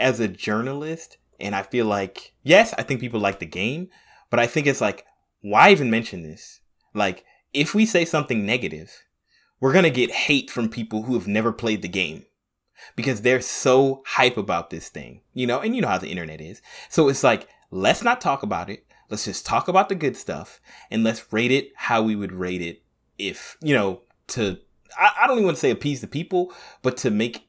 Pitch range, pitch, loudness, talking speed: 105-140 Hz, 120 Hz, -22 LUFS, 210 wpm